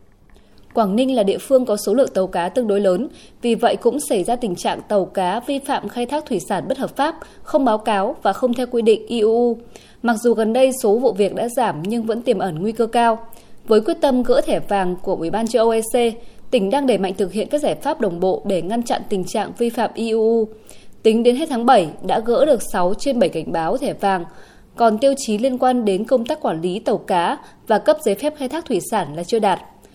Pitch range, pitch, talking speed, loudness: 200-255 Hz, 230 Hz, 250 wpm, -19 LUFS